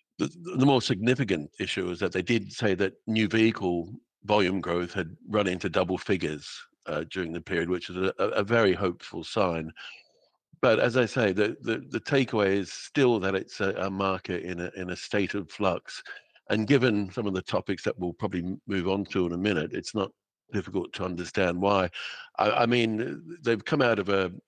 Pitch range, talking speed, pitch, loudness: 90-110 Hz, 200 wpm, 95 Hz, -28 LUFS